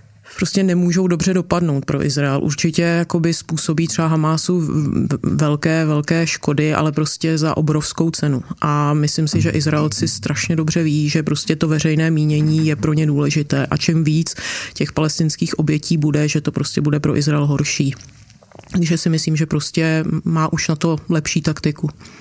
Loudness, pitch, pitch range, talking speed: -18 LUFS, 155 Hz, 150-165 Hz, 165 wpm